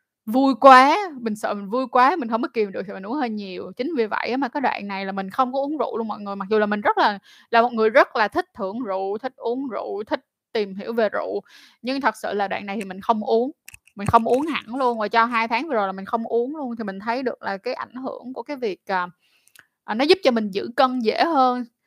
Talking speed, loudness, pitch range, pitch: 275 wpm, -22 LUFS, 210-265 Hz, 235 Hz